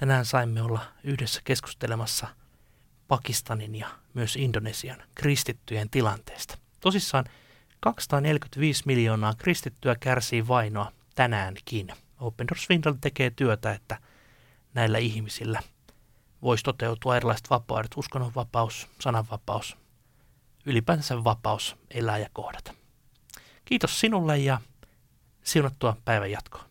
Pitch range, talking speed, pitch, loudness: 110-135 Hz, 95 wpm, 120 Hz, -28 LUFS